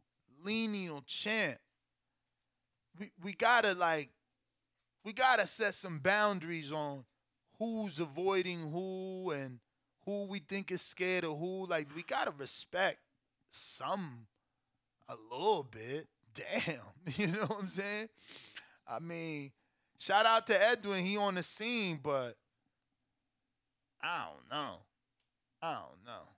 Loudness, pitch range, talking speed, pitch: -35 LUFS, 145-205 Hz, 125 wpm, 180 Hz